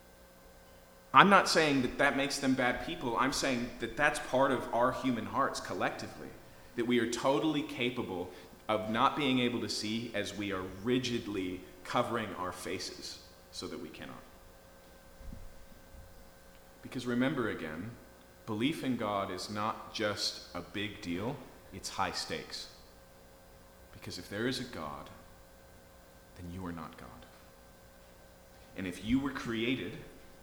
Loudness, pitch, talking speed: -33 LUFS, 100 Hz, 140 wpm